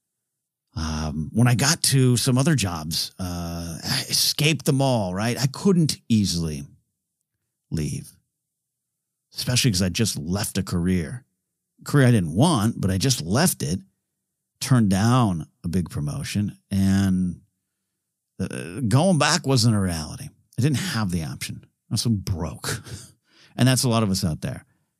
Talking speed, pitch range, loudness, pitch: 155 wpm, 95-135 Hz, -22 LUFS, 115 Hz